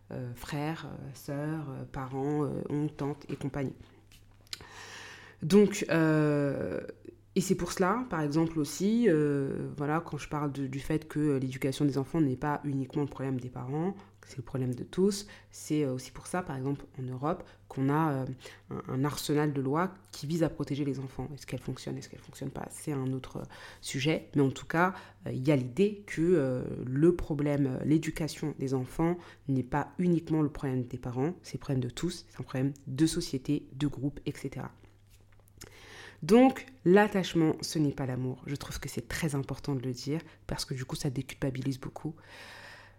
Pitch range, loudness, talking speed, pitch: 130-160 Hz, -31 LUFS, 185 wpm, 145 Hz